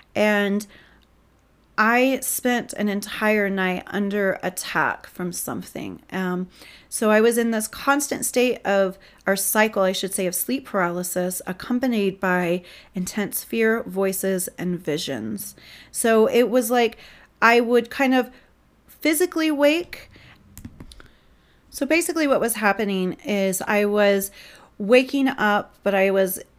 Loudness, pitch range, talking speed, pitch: -22 LUFS, 190-245 Hz, 130 wpm, 205 Hz